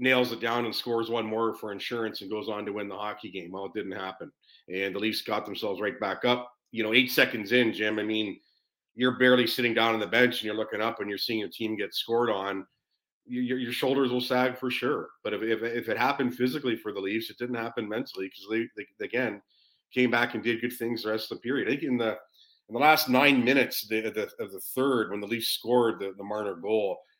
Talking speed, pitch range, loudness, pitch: 245 wpm, 110-125 Hz, -28 LUFS, 115 Hz